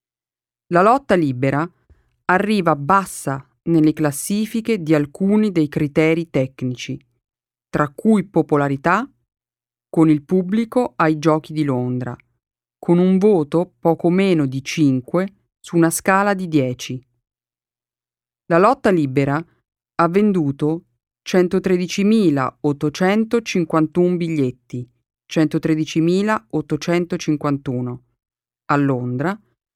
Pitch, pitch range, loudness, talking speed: 160 Hz, 135-185 Hz, -18 LUFS, 90 wpm